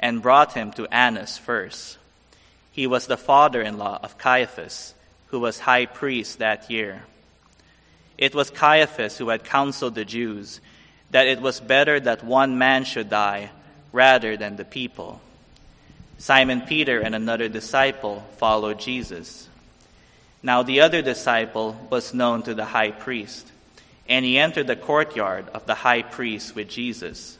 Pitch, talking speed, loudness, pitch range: 120 Hz, 150 wpm, -21 LUFS, 110-130 Hz